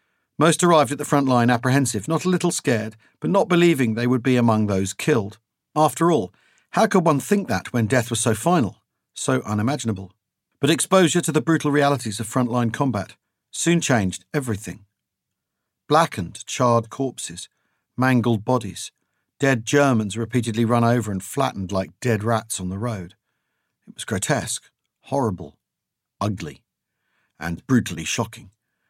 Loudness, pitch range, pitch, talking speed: -21 LUFS, 110-145 Hz, 120 Hz, 150 wpm